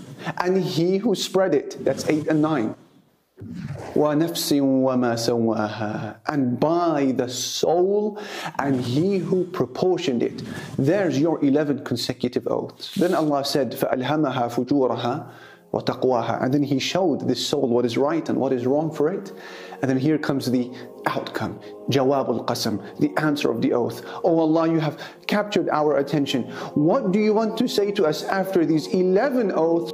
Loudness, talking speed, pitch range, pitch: -22 LUFS, 145 wpm, 125-180 Hz, 145 Hz